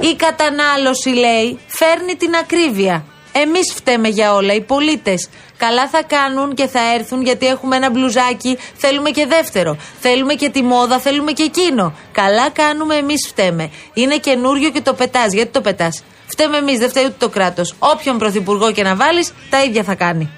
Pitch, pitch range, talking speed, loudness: 260 Hz, 215-295 Hz, 175 wpm, -14 LUFS